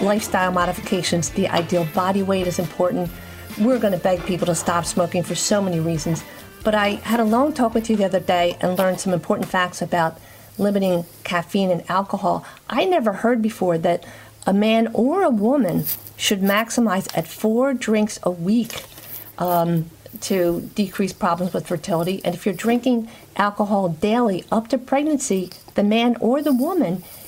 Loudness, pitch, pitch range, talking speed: -21 LUFS, 190 Hz, 175-220 Hz, 170 wpm